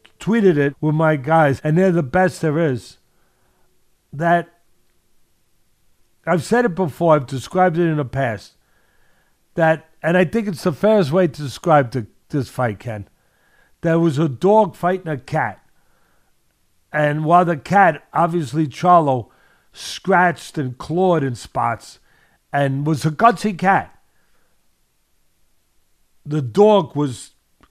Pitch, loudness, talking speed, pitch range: 160 Hz, -18 LUFS, 135 wpm, 135-180 Hz